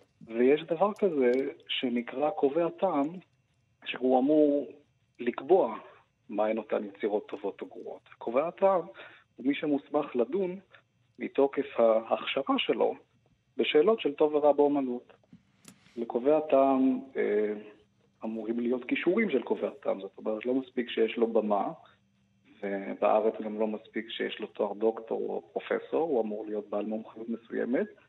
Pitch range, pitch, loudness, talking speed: 110-150 Hz, 130 Hz, -29 LUFS, 130 wpm